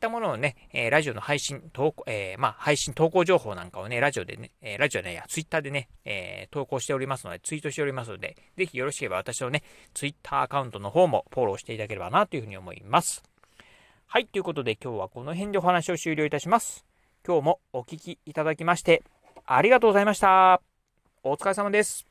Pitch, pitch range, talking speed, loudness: 150 Hz, 130-175 Hz, 490 characters per minute, -26 LUFS